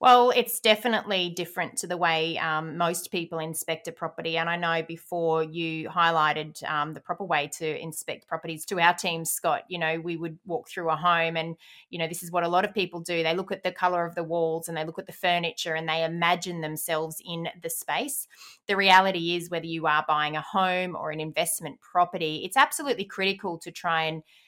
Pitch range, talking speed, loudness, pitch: 160-180 Hz, 220 wpm, -27 LUFS, 170 Hz